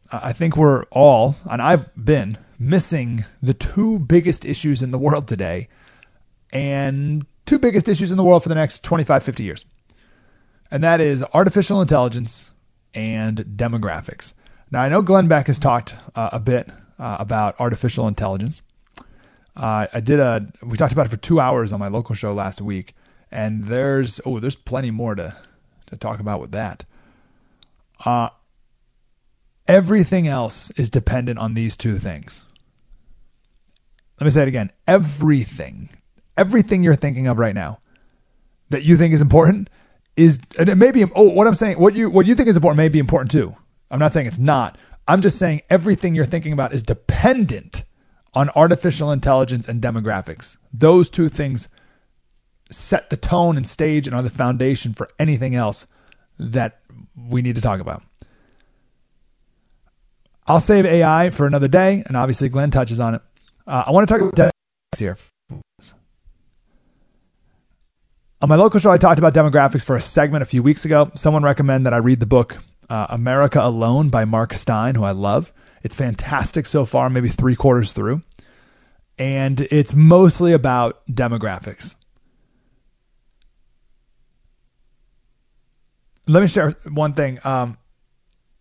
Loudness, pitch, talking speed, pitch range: -17 LUFS, 130 Hz, 160 wpm, 115-155 Hz